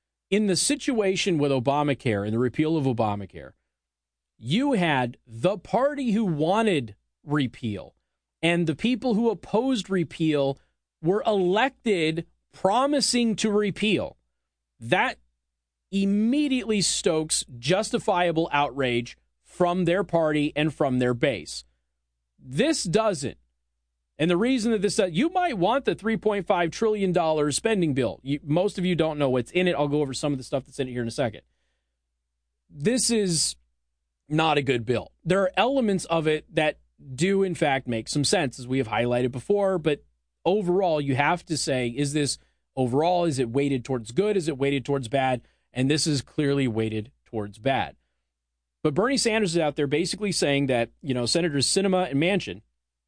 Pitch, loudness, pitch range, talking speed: 150 Hz, -25 LUFS, 120-190 Hz, 165 wpm